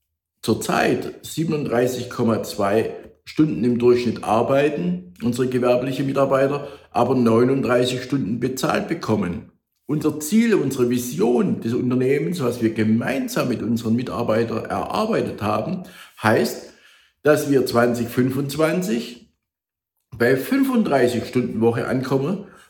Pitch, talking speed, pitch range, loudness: 125 Hz, 100 wpm, 120-145 Hz, -21 LUFS